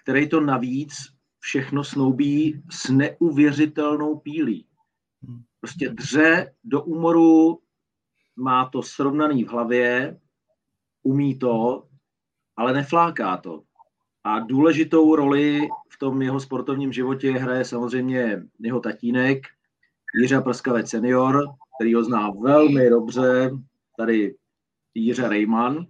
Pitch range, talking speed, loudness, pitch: 120-150 Hz, 105 wpm, -21 LUFS, 135 Hz